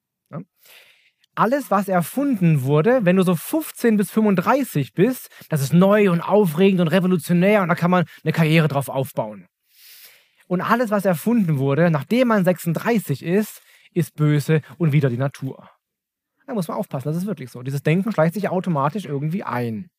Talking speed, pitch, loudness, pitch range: 170 wpm, 180 Hz, -20 LUFS, 155-205 Hz